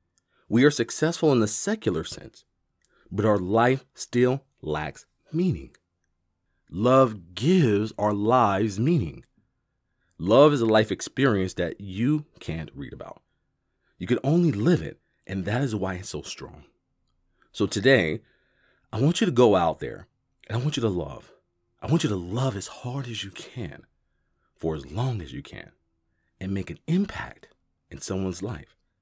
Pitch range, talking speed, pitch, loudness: 90-135 Hz, 160 wpm, 110 Hz, -25 LUFS